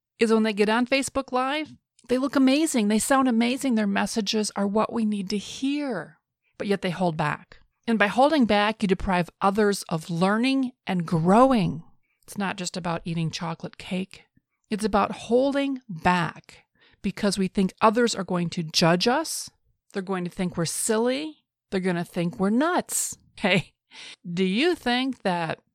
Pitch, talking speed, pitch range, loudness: 205 Hz, 170 wpm, 180-245 Hz, -24 LUFS